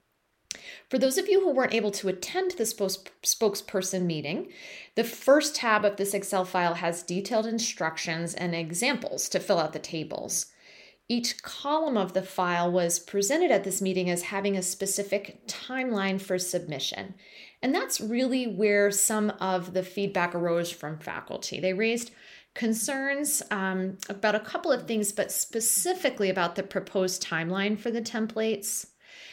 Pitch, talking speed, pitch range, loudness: 200 Hz, 155 wpm, 185-230 Hz, -28 LUFS